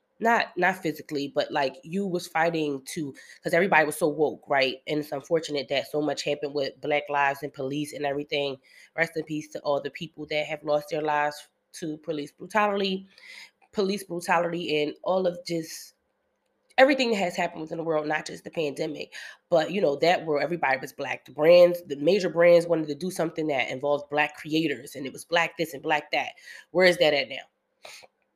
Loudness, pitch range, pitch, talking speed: -26 LUFS, 150-175 Hz, 155 Hz, 200 wpm